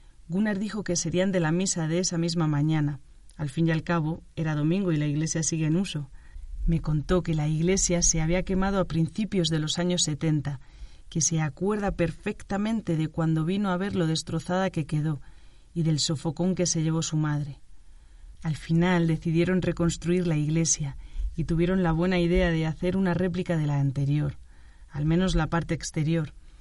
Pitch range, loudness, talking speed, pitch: 155-180 Hz, -26 LUFS, 185 wpm, 165 Hz